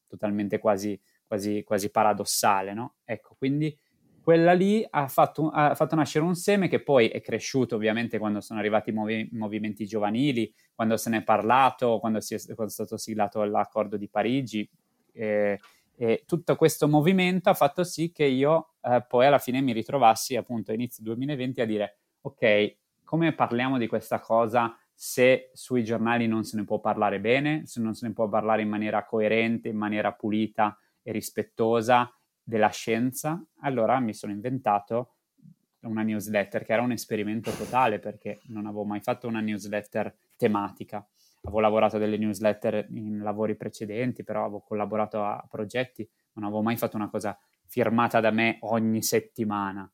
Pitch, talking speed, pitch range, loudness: 110 Hz, 165 wpm, 105-125 Hz, -26 LUFS